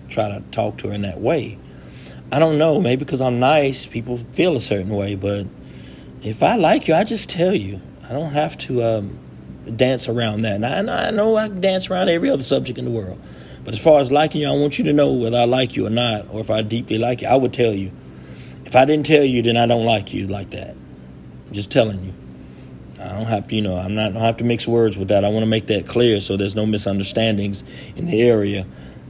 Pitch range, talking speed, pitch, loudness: 100-130 Hz, 250 wpm, 110 Hz, -19 LUFS